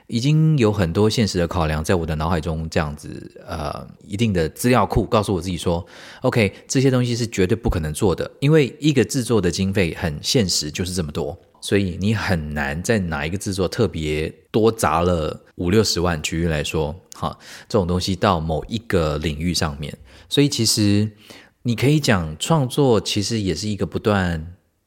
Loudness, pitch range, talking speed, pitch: -21 LUFS, 85-110 Hz, 285 characters per minute, 95 Hz